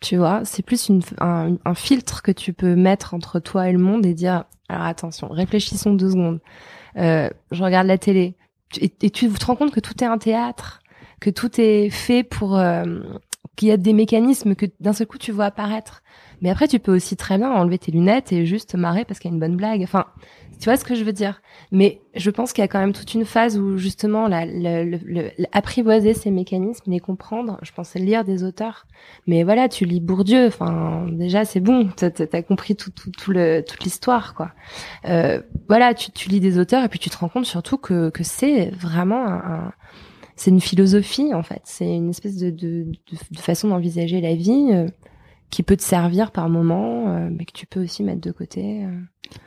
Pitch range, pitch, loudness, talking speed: 175-215 Hz, 190 Hz, -20 LUFS, 225 wpm